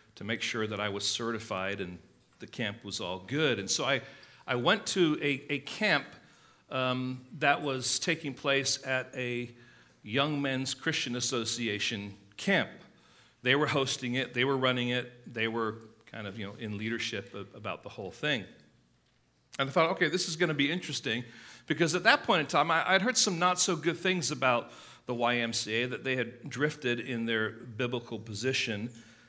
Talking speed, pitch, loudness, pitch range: 185 wpm, 125 Hz, -30 LUFS, 115-145 Hz